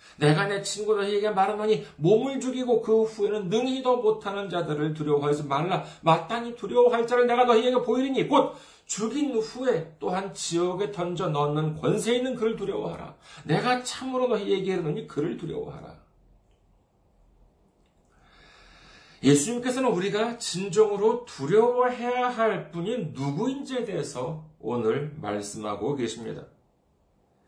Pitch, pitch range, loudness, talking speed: 205 Hz, 155-235 Hz, -26 LUFS, 305 characters per minute